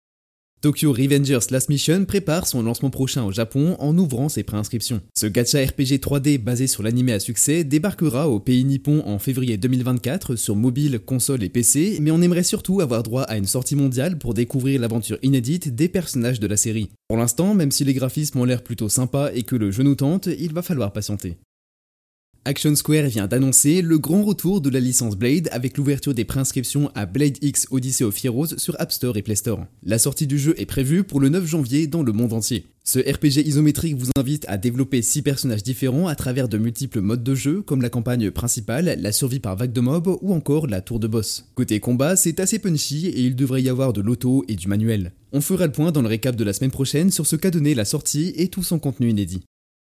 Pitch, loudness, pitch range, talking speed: 135 Hz, -20 LUFS, 120-150 Hz, 220 wpm